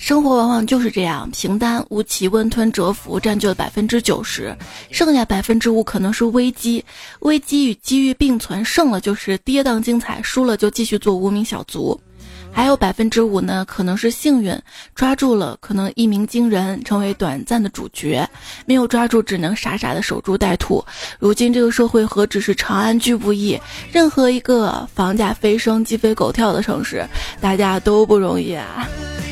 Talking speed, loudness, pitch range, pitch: 280 characters per minute, -17 LUFS, 200-240 Hz, 220 Hz